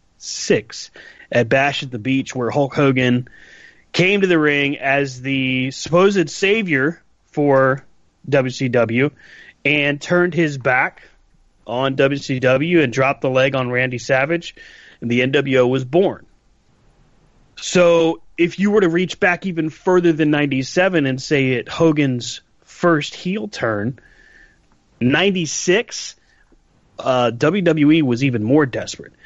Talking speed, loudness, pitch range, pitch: 125 wpm, -17 LUFS, 130-165 Hz, 140 Hz